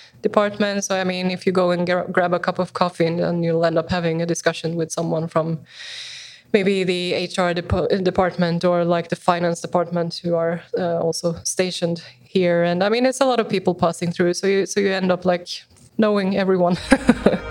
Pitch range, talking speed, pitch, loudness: 170-195 Hz, 205 wpm, 180 Hz, -20 LUFS